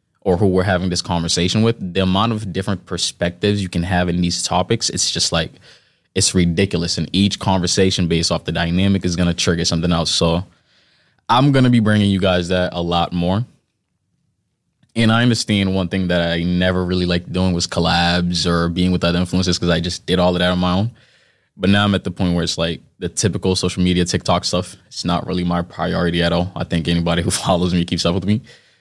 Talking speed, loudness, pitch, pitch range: 220 wpm, -18 LUFS, 90 Hz, 85-95 Hz